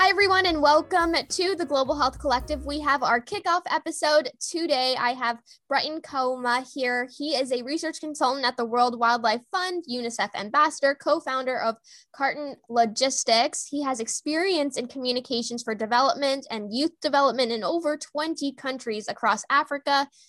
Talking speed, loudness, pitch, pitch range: 155 wpm, -25 LUFS, 275 Hz, 245-305 Hz